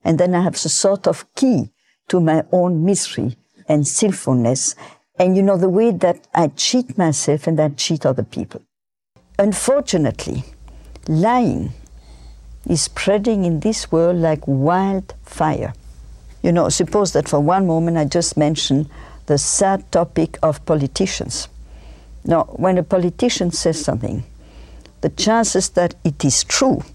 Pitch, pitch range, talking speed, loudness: 165 Hz, 140-190 Hz, 145 wpm, -18 LUFS